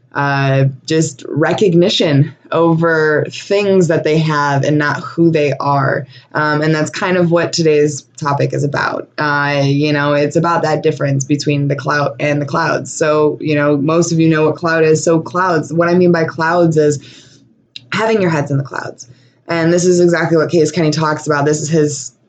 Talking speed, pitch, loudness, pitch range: 195 wpm, 150 Hz, -14 LUFS, 145-165 Hz